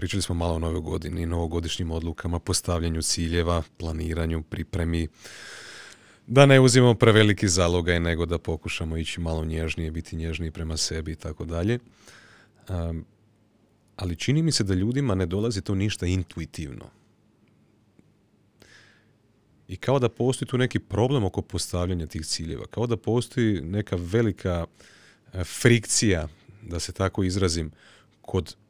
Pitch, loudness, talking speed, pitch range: 90 Hz, -25 LUFS, 135 wpm, 85-110 Hz